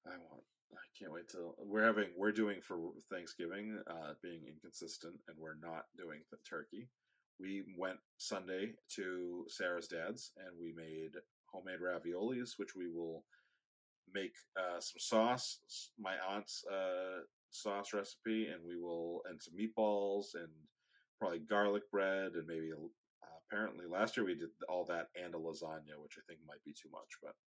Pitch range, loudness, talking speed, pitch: 85-105 Hz, -43 LUFS, 165 wpm, 95 Hz